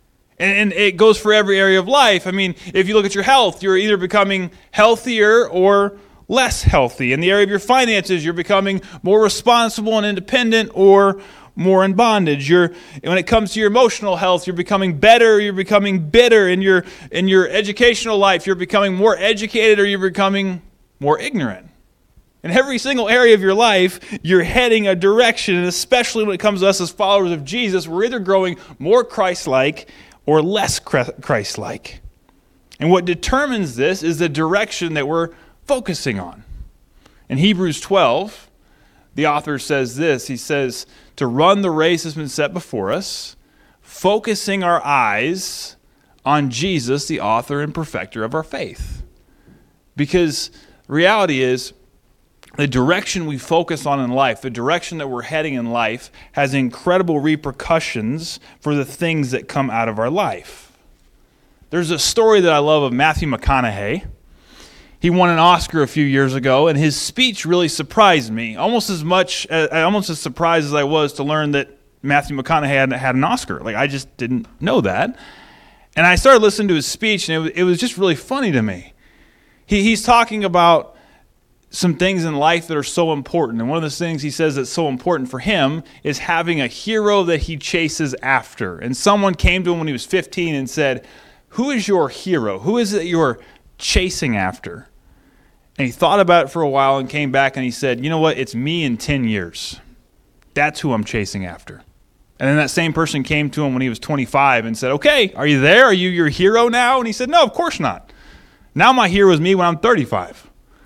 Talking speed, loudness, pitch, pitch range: 190 wpm, -16 LUFS, 175 Hz, 145-200 Hz